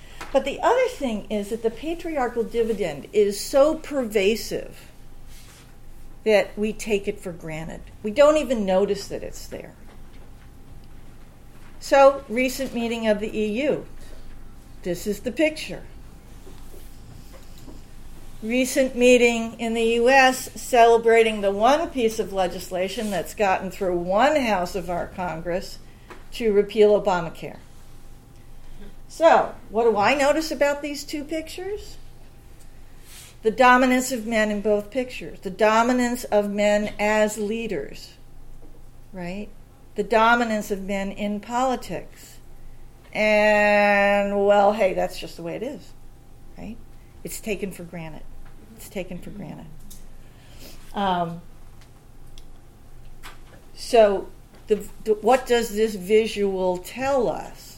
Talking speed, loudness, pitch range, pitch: 120 wpm, -22 LUFS, 195-245 Hz, 210 Hz